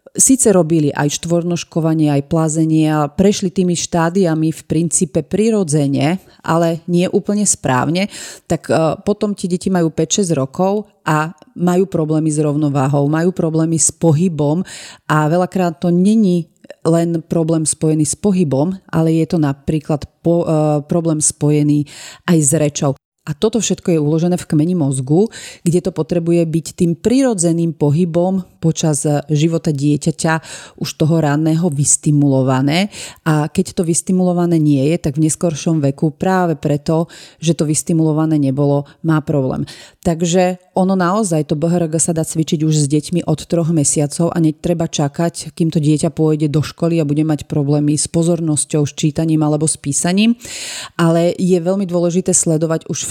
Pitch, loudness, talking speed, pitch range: 165 Hz, -16 LUFS, 150 wpm, 155-175 Hz